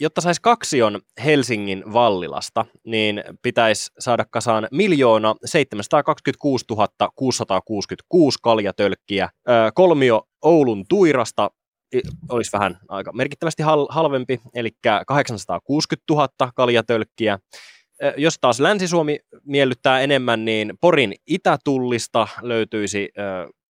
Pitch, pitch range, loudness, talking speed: 120 Hz, 110-140 Hz, -19 LUFS, 85 wpm